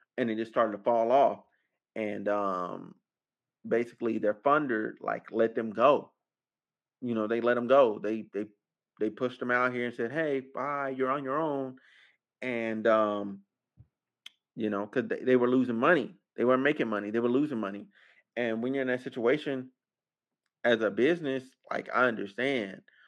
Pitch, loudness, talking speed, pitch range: 120 Hz, -29 LUFS, 175 wpm, 110-130 Hz